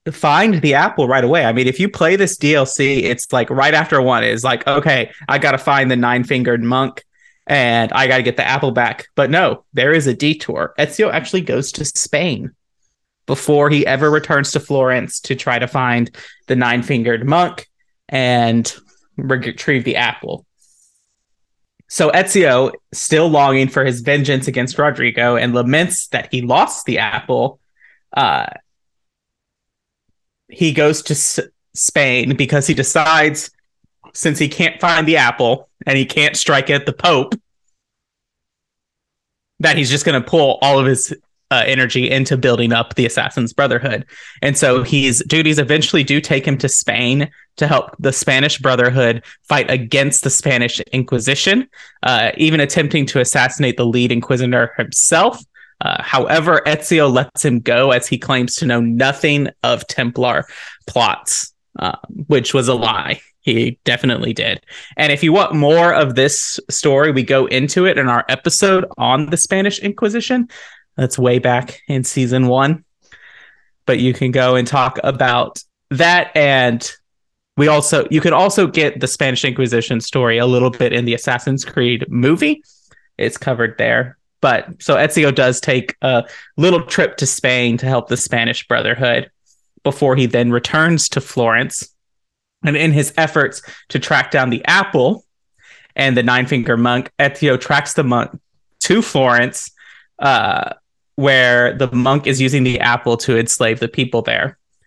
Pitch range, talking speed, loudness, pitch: 125-150 Hz, 160 wpm, -15 LUFS, 135 Hz